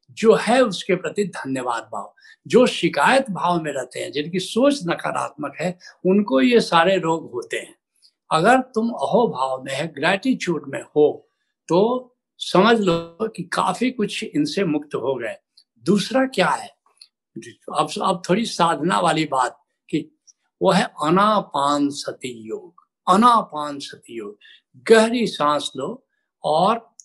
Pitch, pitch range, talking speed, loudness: 190 Hz, 155-235 Hz, 140 wpm, -20 LUFS